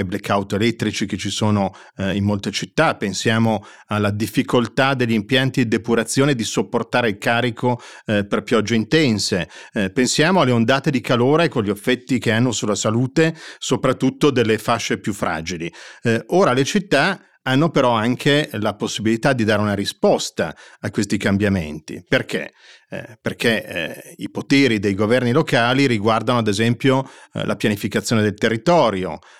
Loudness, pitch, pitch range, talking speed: -19 LUFS, 115 Hz, 105-130 Hz, 155 wpm